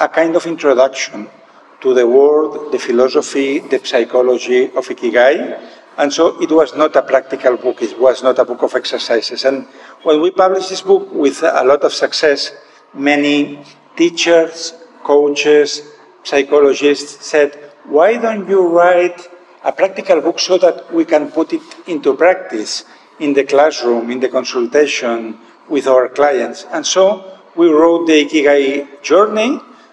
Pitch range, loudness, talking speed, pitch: 140-190 Hz, -13 LUFS, 150 wpm, 155 Hz